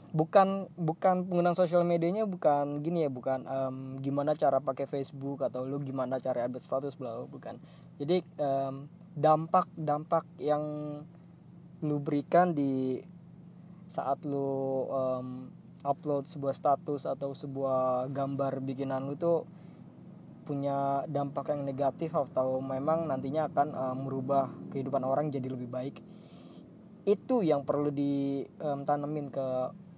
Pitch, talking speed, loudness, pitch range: 145 Hz, 125 wpm, -32 LUFS, 135-165 Hz